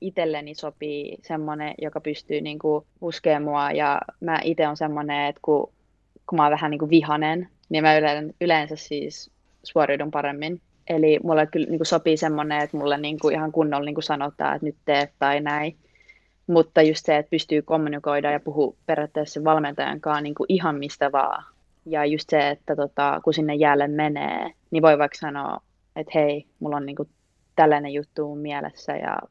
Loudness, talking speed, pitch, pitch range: -23 LUFS, 170 wpm, 150 Hz, 145-155 Hz